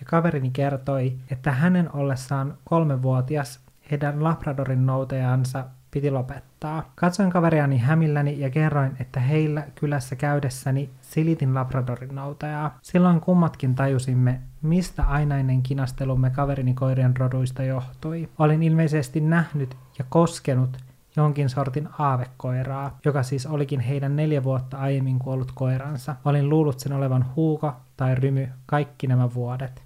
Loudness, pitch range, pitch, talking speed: -24 LUFS, 130-150 Hz, 140 Hz, 125 wpm